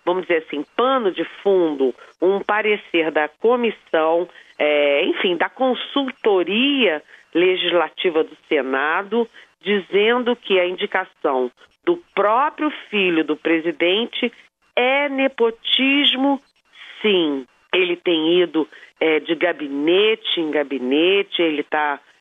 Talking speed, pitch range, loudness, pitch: 105 wpm, 160-245 Hz, -19 LUFS, 185 Hz